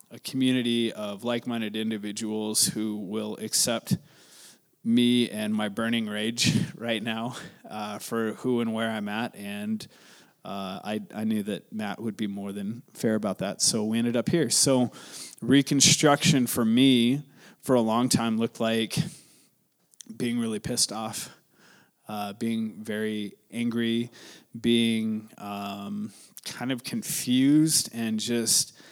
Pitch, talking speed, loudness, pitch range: 115 Hz, 140 wpm, -26 LUFS, 110-125 Hz